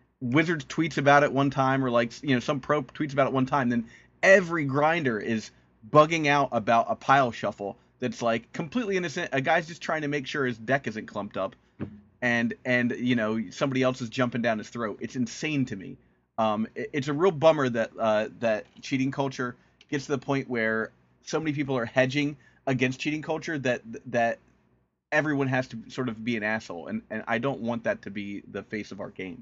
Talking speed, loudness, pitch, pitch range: 215 wpm, -27 LUFS, 130 Hz, 115-145 Hz